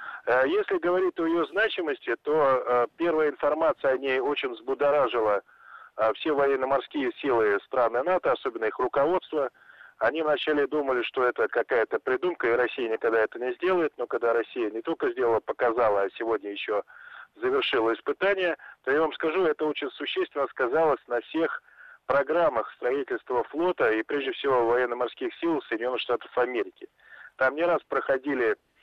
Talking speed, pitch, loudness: 145 wpm, 290 Hz, -26 LUFS